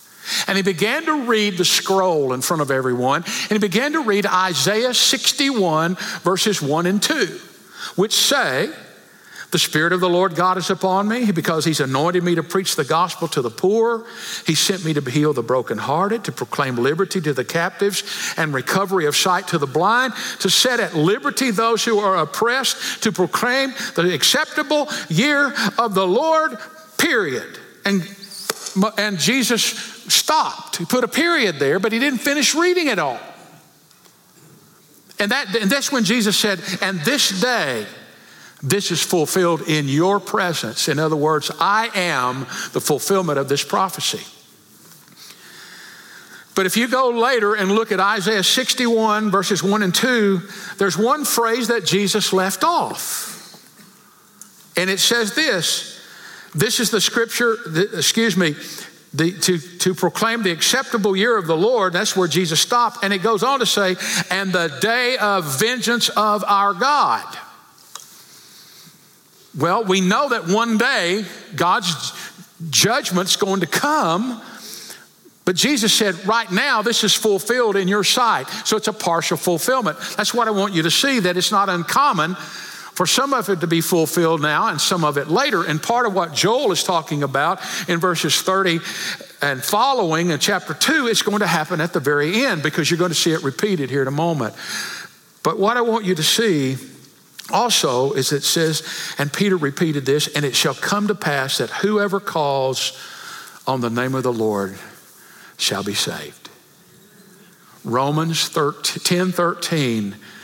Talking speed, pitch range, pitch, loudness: 165 wpm, 165-225 Hz, 195 Hz, -18 LUFS